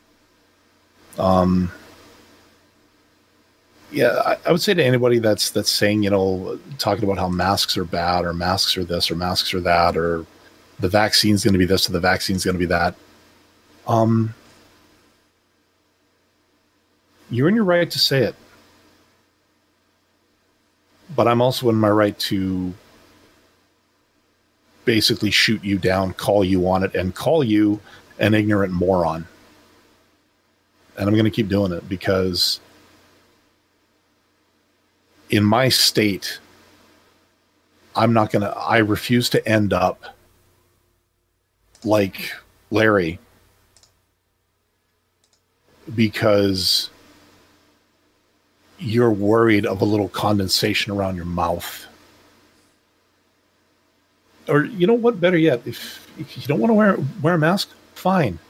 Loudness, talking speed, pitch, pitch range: -19 LUFS, 120 wpm, 100 Hz, 90-115 Hz